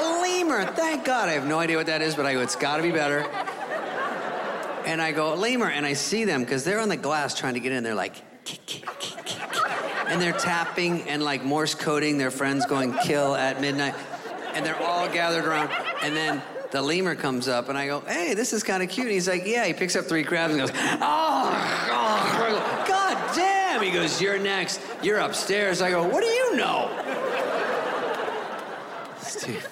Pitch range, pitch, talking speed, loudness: 145-195 Hz, 165 Hz, 205 wpm, -25 LUFS